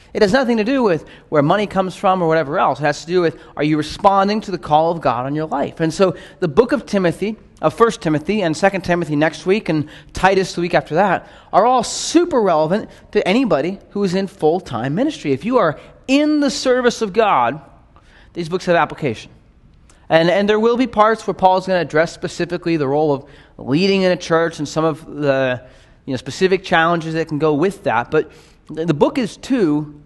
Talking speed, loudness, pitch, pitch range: 220 wpm, -17 LUFS, 175 Hz, 155-200 Hz